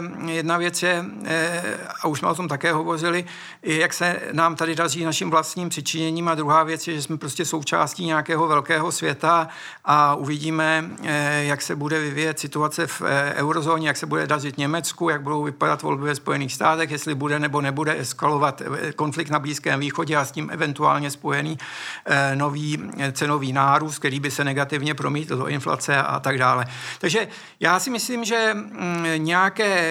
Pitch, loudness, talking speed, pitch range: 155 Hz, -22 LUFS, 165 wpm, 145-170 Hz